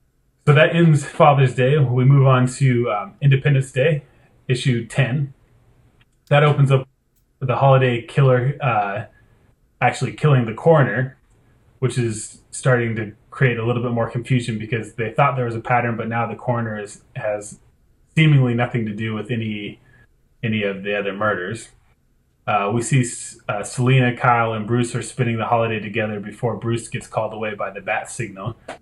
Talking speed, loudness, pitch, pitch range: 170 wpm, -19 LUFS, 120 Hz, 115-130 Hz